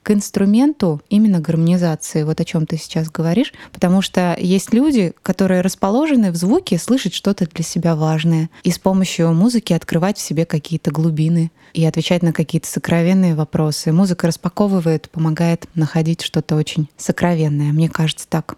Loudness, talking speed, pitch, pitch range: -17 LUFS, 155 wpm, 170 Hz, 160-190 Hz